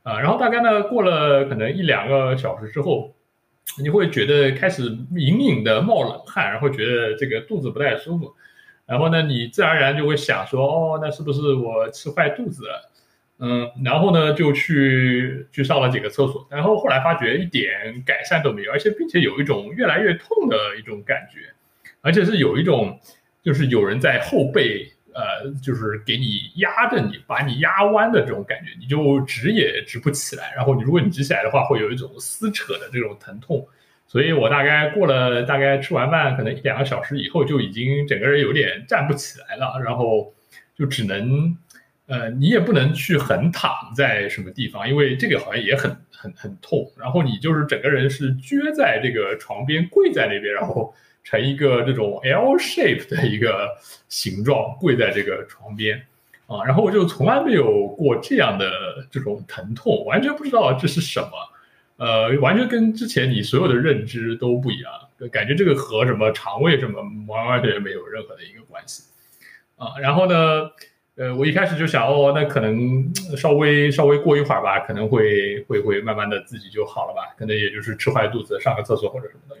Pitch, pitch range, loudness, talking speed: 140 Hz, 130-170 Hz, -20 LUFS, 295 characters per minute